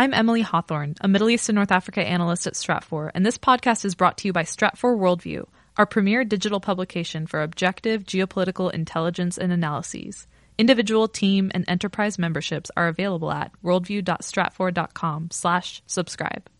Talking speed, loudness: 150 wpm, -23 LUFS